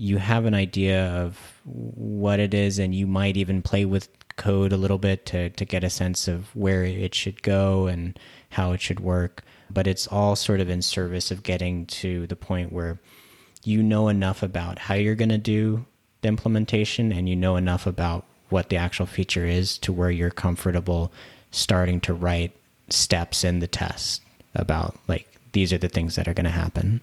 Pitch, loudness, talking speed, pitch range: 95 Hz, -24 LUFS, 200 wpm, 90-100 Hz